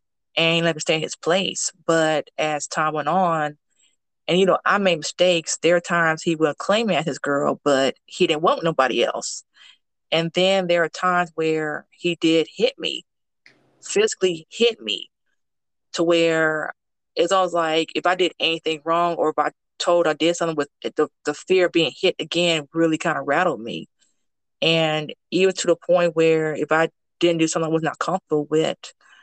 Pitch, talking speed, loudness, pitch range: 165 Hz, 195 wpm, -21 LUFS, 155-175 Hz